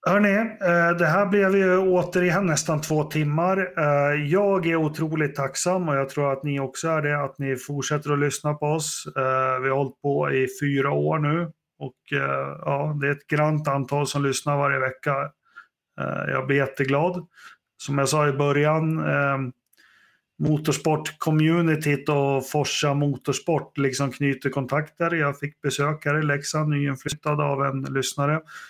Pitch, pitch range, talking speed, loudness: 145 Hz, 140-160 Hz, 155 wpm, -23 LUFS